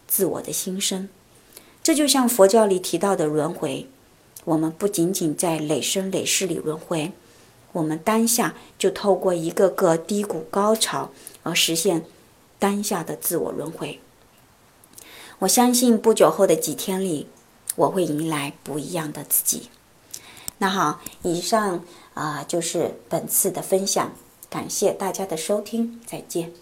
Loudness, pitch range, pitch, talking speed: -22 LUFS, 160-205 Hz, 185 Hz, 215 characters per minute